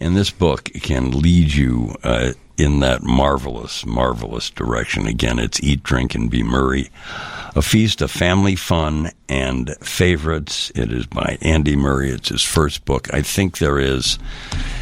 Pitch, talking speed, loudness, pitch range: 70 Hz, 160 wpm, -18 LUFS, 65-80 Hz